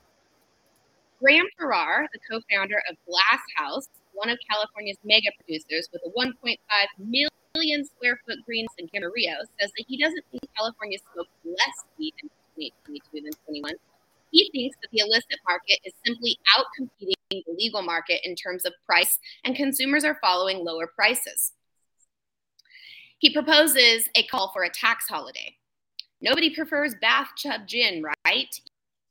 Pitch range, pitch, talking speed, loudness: 190-285 Hz, 225 Hz, 145 wpm, -23 LUFS